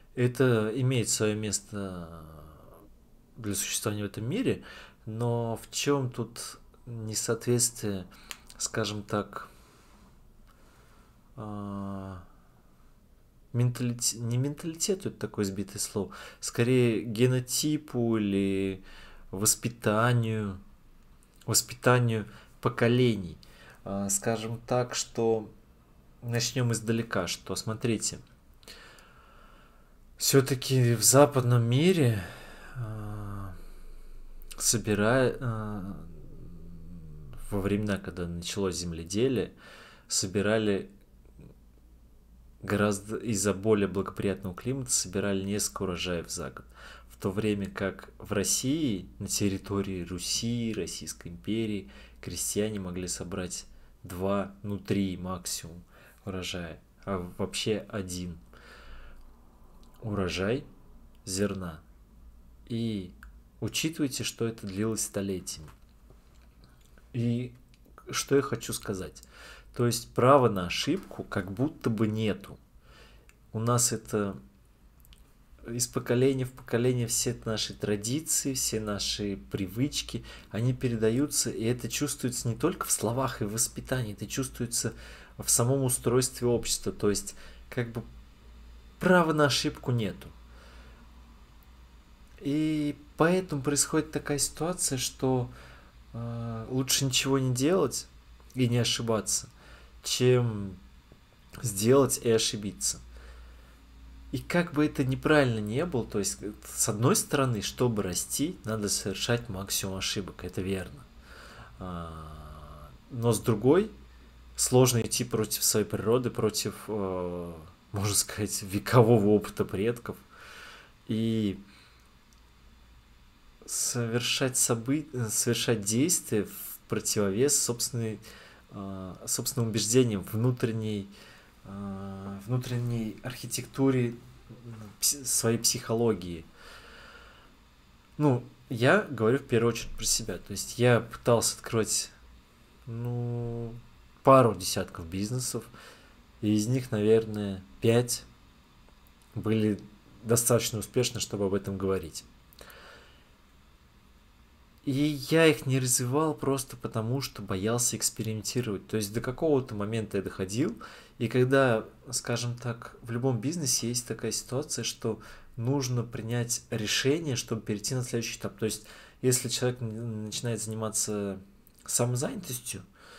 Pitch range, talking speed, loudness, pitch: 95-120 Hz, 95 wpm, -29 LUFS, 110 Hz